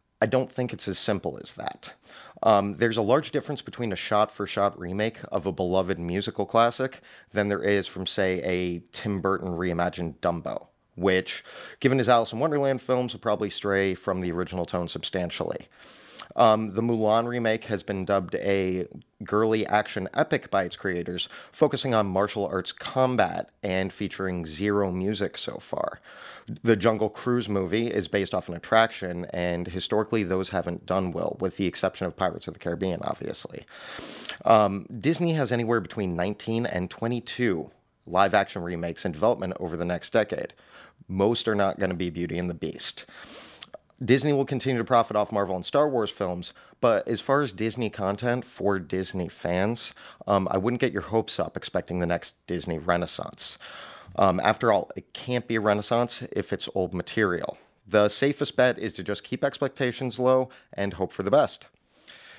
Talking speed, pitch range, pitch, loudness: 175 wpm, 90-115 Hz, 100 Hz, -26 LUFS